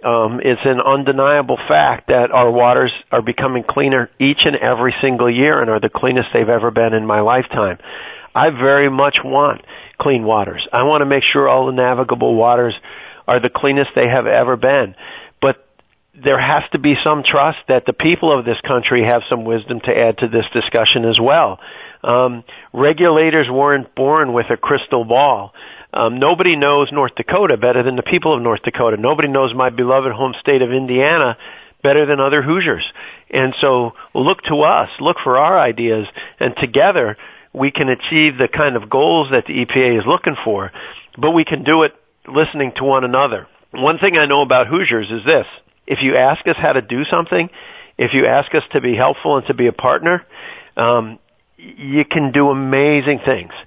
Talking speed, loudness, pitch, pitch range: 190 wpm, -14 LUFS, 130 Hz, 120-145 Hz